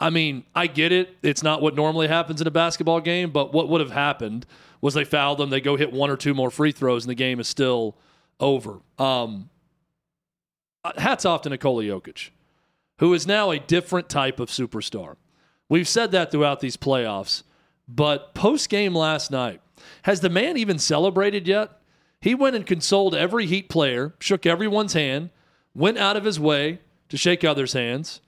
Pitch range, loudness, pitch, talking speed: 140-175 Hz, -22 LUFS, 160 Hz, 185 wpm